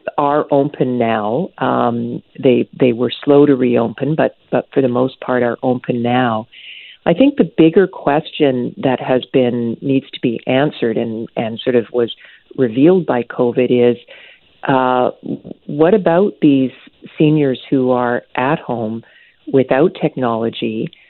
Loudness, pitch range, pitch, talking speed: -16 LUFS, 120-150 Hz, 130 Hz, 145 wpm